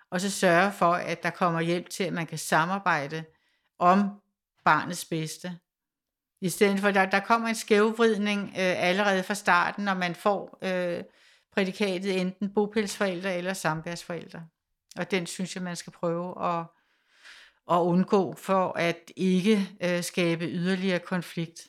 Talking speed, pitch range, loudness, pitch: 150 wpm, 170-200 Hz, -27 LUFS, 180 Hz